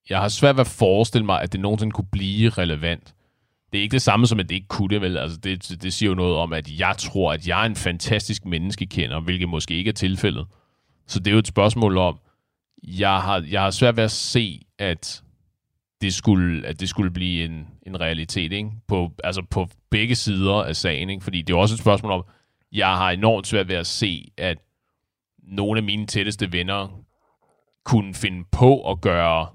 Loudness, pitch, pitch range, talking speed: -22 LUFS, 95 Hz, 90-105 Hz, 215 wpm